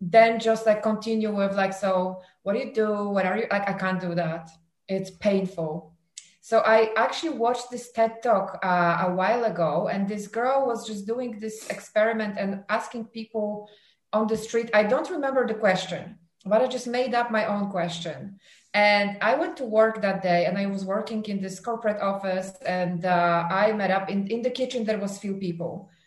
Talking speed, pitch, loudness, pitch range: 200 wpm, 205 Hz, -25 LUFS, 185-225 Hz